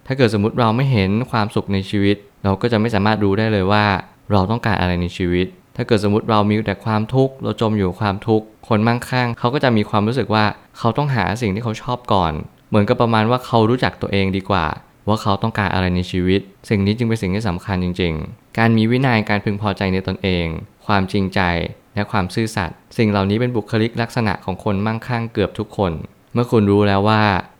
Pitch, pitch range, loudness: 105 Hz, 100-115 Hz, -18 LUFS